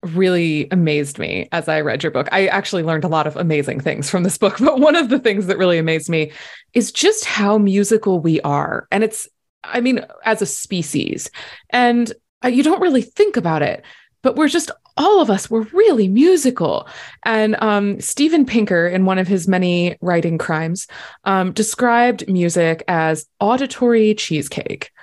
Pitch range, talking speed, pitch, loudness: 170-240 Hz, 175 wpm, 195 Hz, -17 LUFS